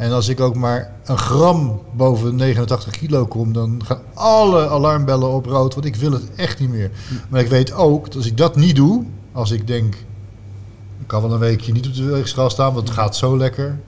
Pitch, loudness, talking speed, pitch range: 125 Hz, -17 LUFS, 225 wpm, 115-135 Hz